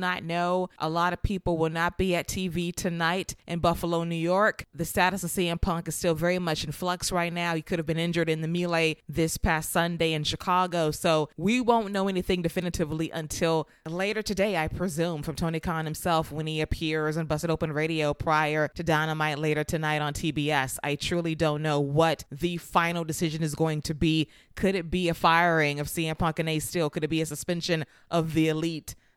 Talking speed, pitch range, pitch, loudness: 210 wpm, 155-175 Hz, 165 Hz, -27 LUFS